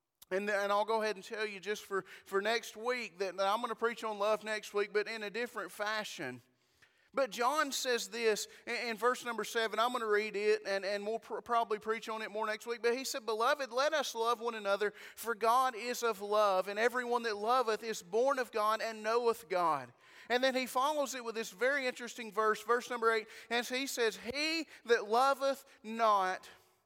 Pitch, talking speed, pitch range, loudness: 225 Hz, 220 wpm, 210-245 Hz, -34 LUFS